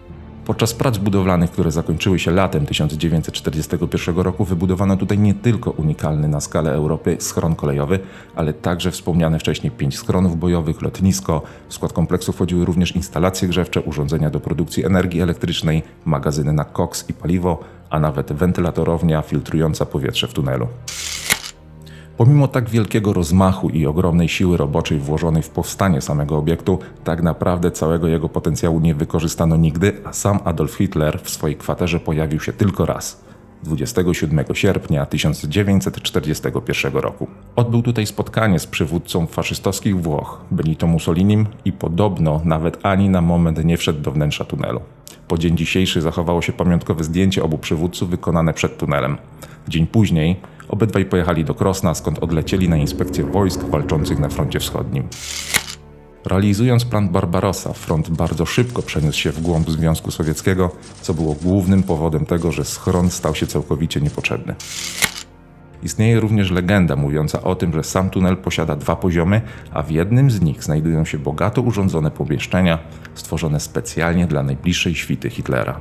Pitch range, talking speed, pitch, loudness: 80-95 Hz, 145 wpm, 85 Hz, -19 LUFS